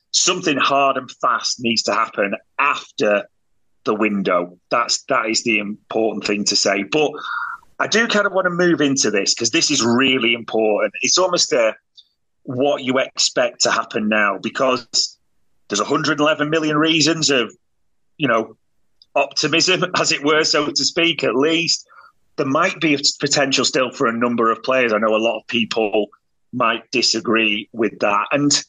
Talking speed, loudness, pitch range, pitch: 170 wpm, -18 LUFS, 110-160 Hz, 140 Hz